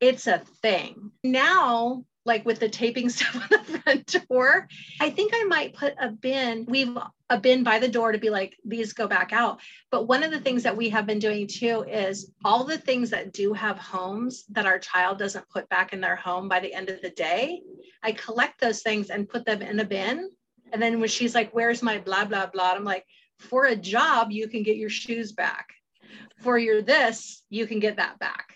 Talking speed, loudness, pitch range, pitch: 225 wpm, -25 LUFS, 210-250 Hz, 230 Hz